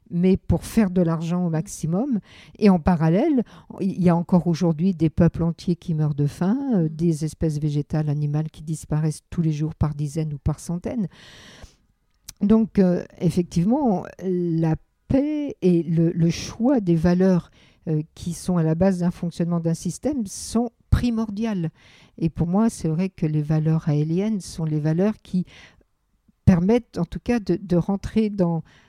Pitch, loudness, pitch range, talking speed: 175 Hz, -23 LUFS, 160-195 Hz, 165 wpm